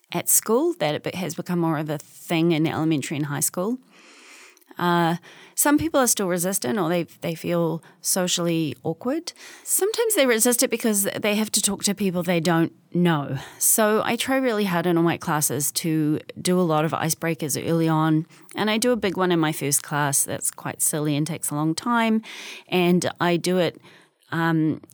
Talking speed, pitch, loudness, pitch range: 195 wpm, 170 Hz, -22 LUFS, 160-210 Hz